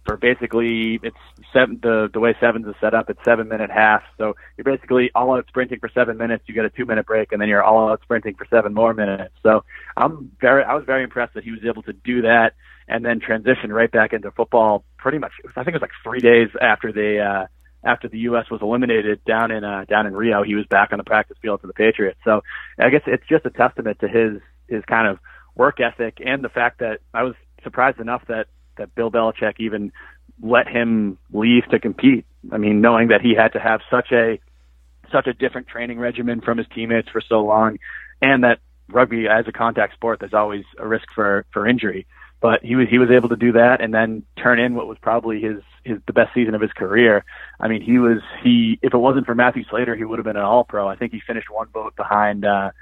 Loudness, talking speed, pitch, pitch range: -18 LUFS, 240 wpm, 115 Hz, 105-120 Hz